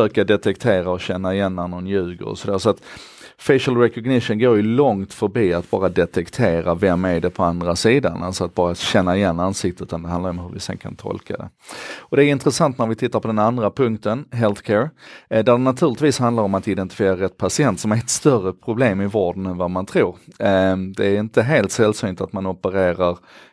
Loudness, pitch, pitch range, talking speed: -19 LUFS, 95 Hz, 90-115 Hz, 205 wpm